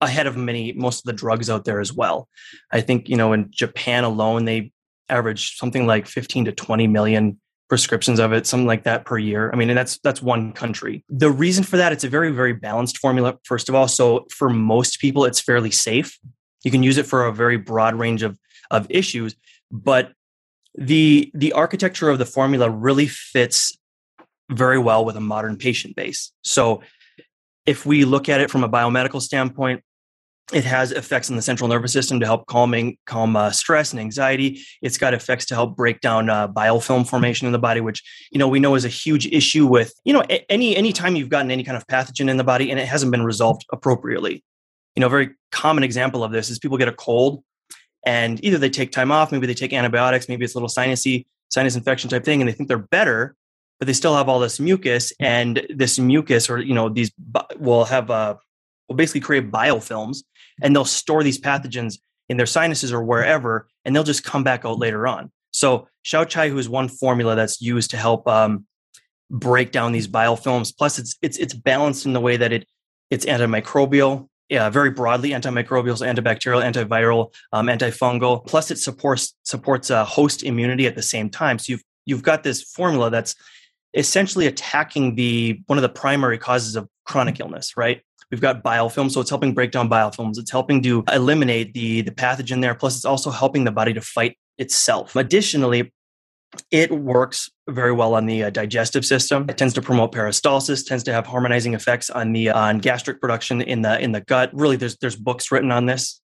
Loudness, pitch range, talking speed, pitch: -19 LUFS, 115-135 Hz, 205 wpm, 125 Hz